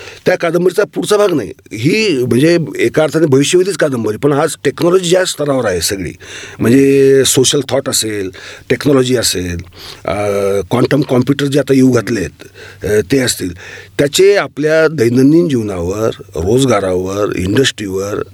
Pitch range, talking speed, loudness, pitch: 110-155 Hz, 130 wpm, -12 LUFS, 135 Hz